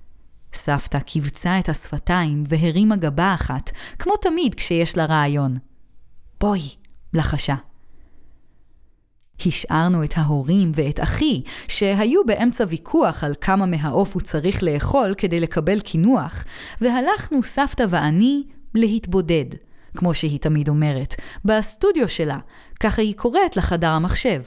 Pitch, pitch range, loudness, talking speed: 170 Hz, 145-210 Hz, -20 LUFS, 115 wpm